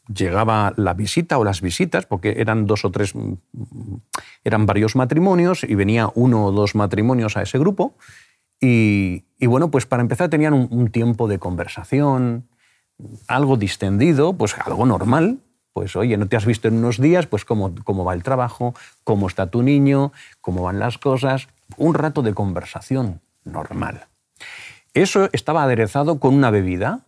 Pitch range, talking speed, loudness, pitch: 105-135 Hz, 165 wpm, -19 LUFS, 115 Hz